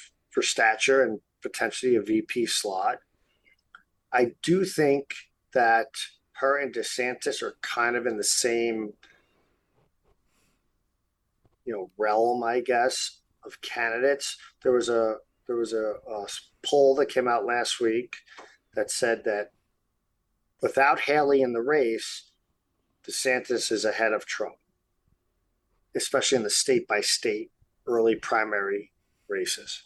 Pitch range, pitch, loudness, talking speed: 115-170 Hz, 125 Hz, -26 LUFS, 125 wpm